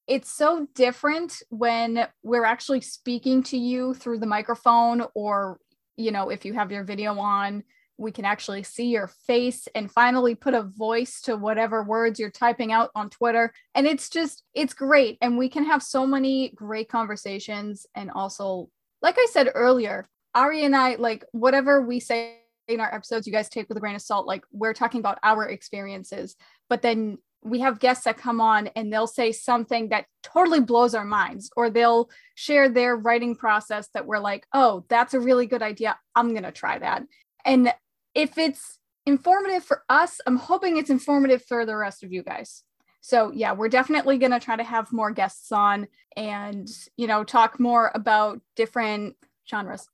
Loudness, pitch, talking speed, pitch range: -23 LUFS, 235 Hz, 185 wpm, 215-255 Hz